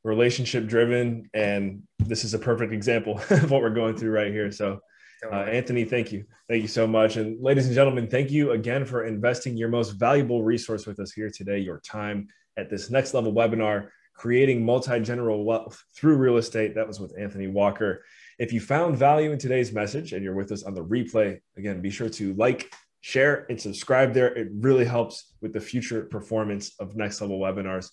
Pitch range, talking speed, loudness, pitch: 105-120 Hz, 200 wpm, -25 LUFS, 110 Hz